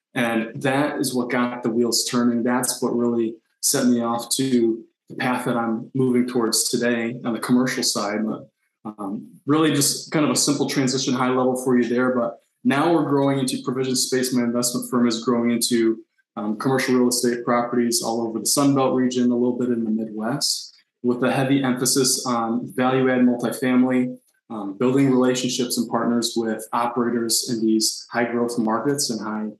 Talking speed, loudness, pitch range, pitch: 185 wpm, -21 LUFS, 115-130 Hz, 125 Hz